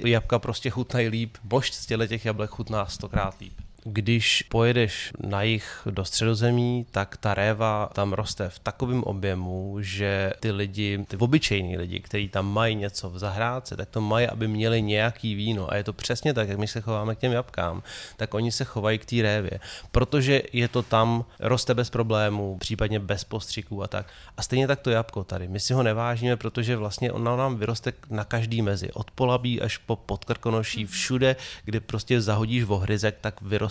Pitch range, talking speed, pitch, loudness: 100-120 Hz, 185 wpm, 110 Hz, -26 LUFS